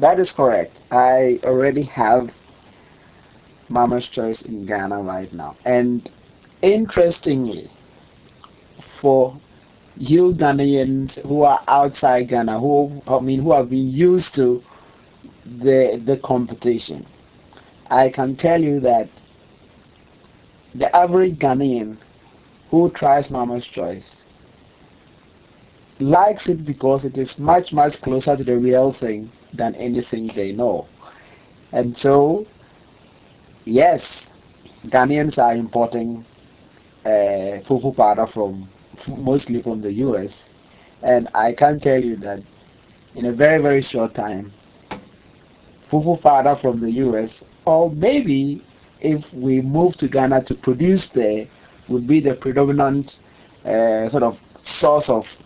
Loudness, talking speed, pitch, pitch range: -18 LUFS, 120 wpm, 130 Hz, 120-145 Hz